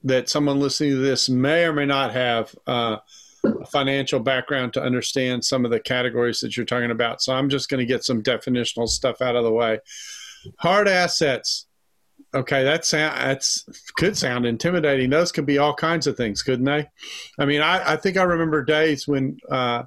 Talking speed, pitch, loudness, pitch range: 195 wpm, 135 Hz, -21 LUFS, 125-150 Hz